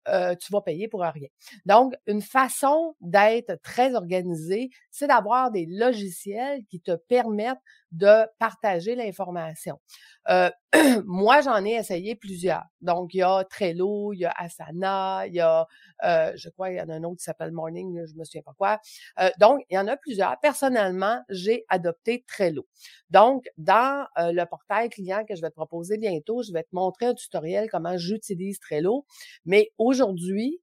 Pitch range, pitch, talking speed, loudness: 175-235 Hz, 200 Hz, 180 wpm, -24 LUFS